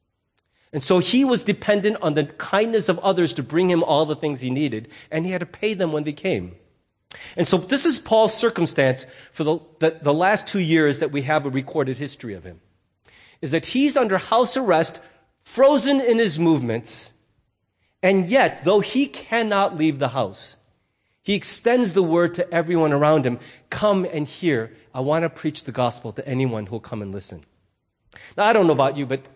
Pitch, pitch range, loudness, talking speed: 155 Hz, 130-195 Hz, -21 LUFS, 195 wpm